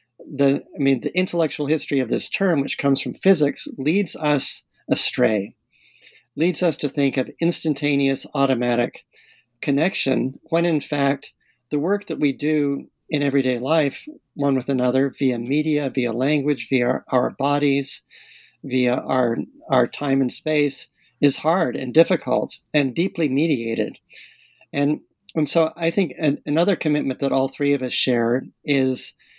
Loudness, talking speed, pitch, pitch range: -21 LUFS, 150 wpm, 140 Hz, 130-155 Hz